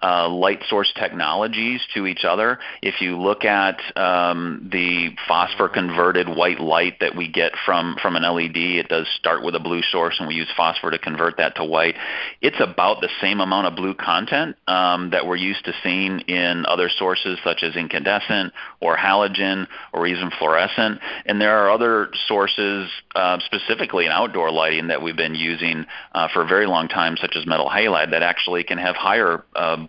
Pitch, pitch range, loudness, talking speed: 90 Hz, 85-95 Hz, -20 LUFS, 195 wpm